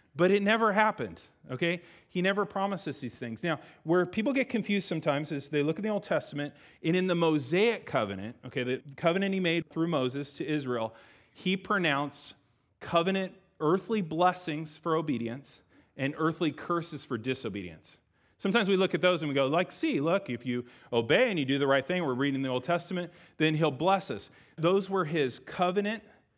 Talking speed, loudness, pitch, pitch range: 185 wpm, -30 LUFS, 165 Hz, 140-185 Hz